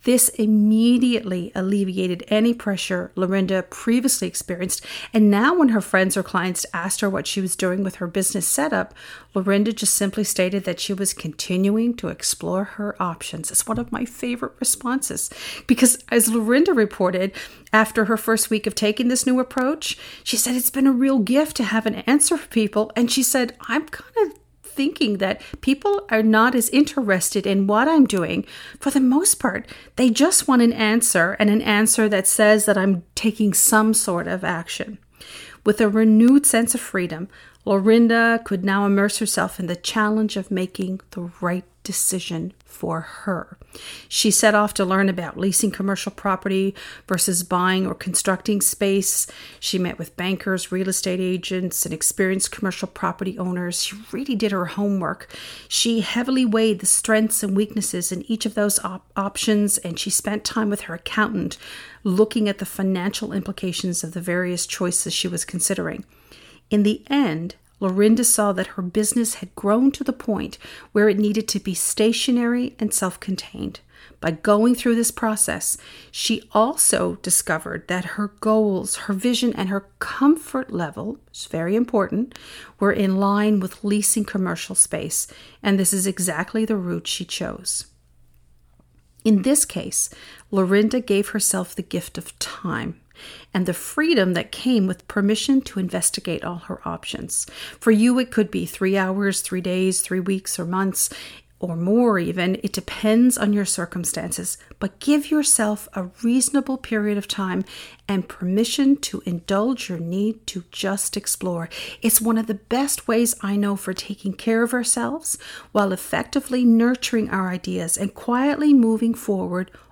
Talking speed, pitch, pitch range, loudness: 165 wpm, 205 Hz, 190-230 Hz, -20 LUFS